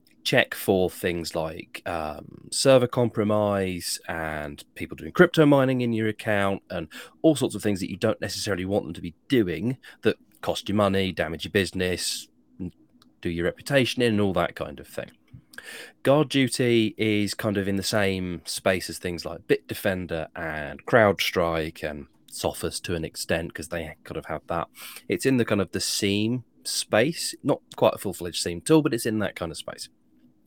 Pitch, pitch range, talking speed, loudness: 100 Hz, 85-115 Hz, 185 wpm, -25 LUFS